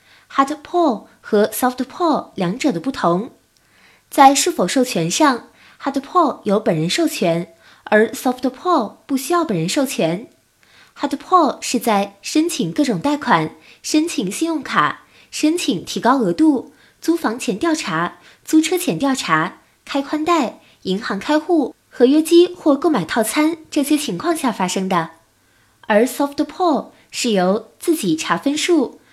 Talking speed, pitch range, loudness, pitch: 260 characters per minute, 210-315 Hz, -18 LUFS, 275 Hz